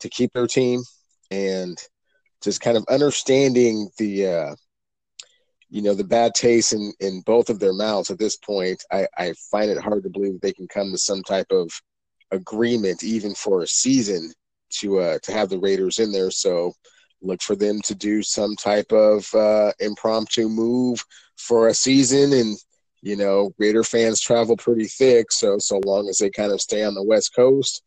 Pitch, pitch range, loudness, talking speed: 115 Hz, 105-130 Hz, -20 LUFS, 185 wpm